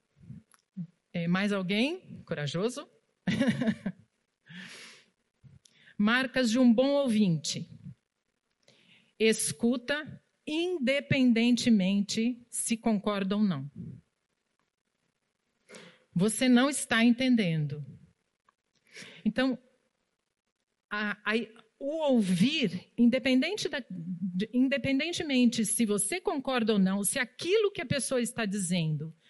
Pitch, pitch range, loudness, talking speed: 225 Hz, 195-260 Hz, -28 LUFS, 80 wpm